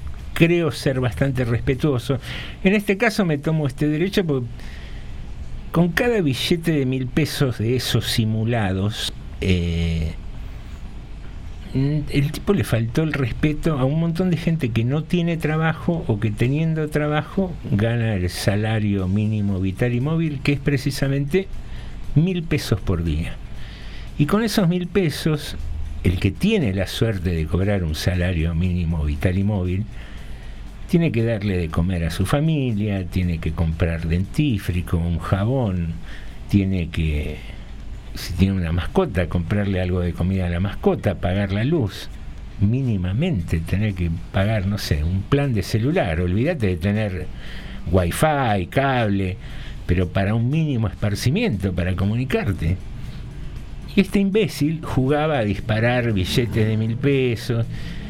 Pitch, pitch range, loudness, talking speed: 110 Hz, 90-145 Hz, -21 LUFS, 140 wpm